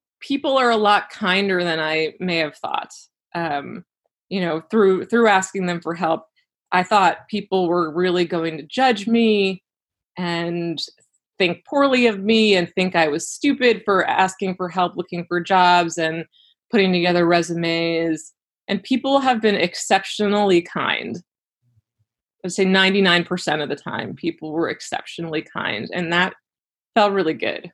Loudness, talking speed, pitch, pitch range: -20 LUFS, 155 wpm, 180 Hz, 165-205 Hz